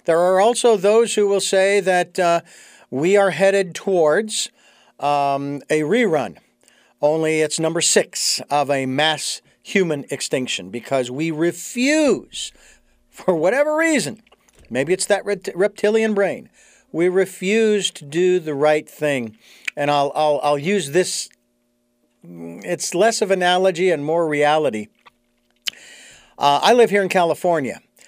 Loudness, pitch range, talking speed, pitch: -19 LUFS, 145-200 Hz, 130 wpm, 170 Hz